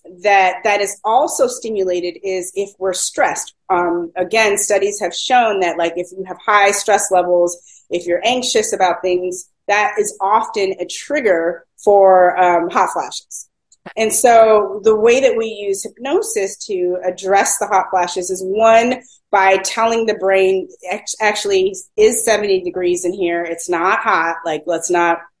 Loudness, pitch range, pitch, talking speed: -15 LUFS, 180-220 Hz, 195 Hz, 160 wpm